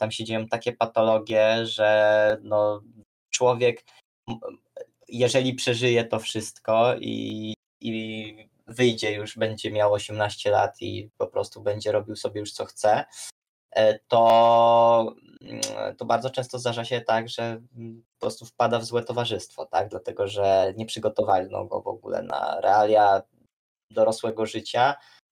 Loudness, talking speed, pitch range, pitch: -24 LUFS, 130 wpm, 110-125 Hz, 115 Hz